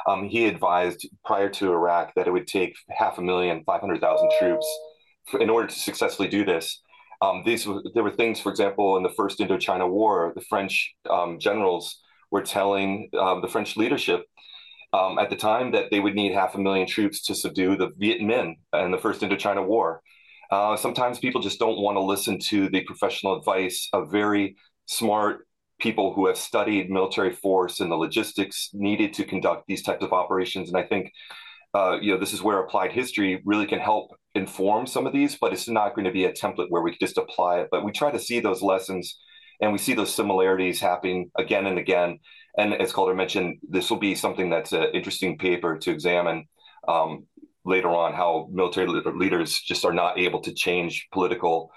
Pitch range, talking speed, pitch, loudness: 95-115 Hz, 200 wpm, 100 Hz, -24 LUFS